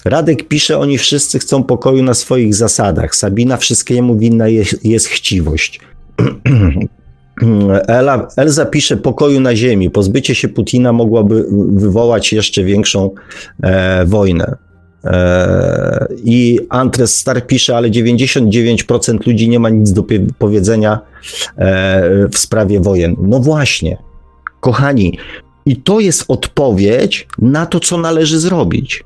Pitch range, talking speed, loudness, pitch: 100-130 Hz, 120 wpm, -11 LUFS, 115 Hz